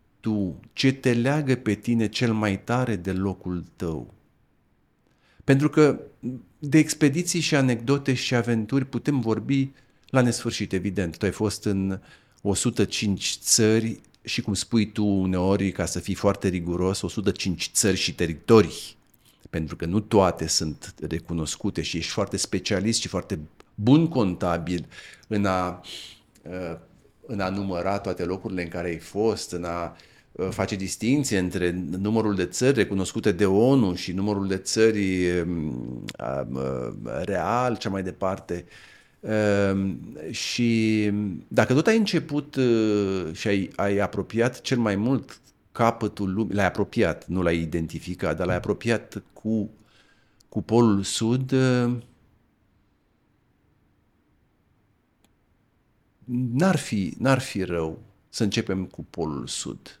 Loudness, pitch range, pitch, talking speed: -25 LUFS, 90-115 Hz, 100 Hz, 125 wpm